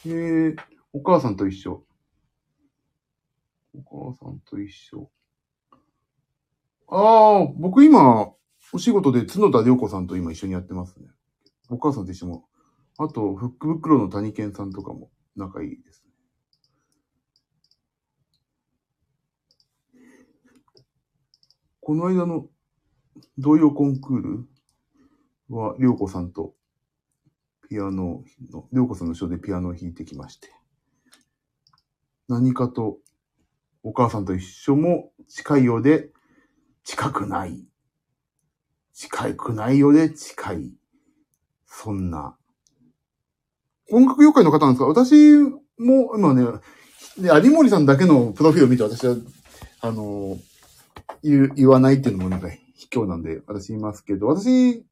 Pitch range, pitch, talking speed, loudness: 100-160 Hz, 135 Hz, 225 characters per minute, -18 LUFS